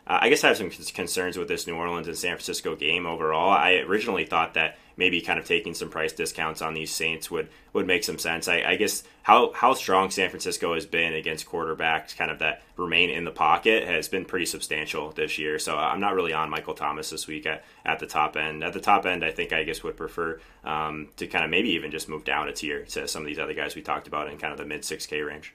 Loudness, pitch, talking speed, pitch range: -25 LUFS, 80 Hz, 265 wpm, 75-80 Hz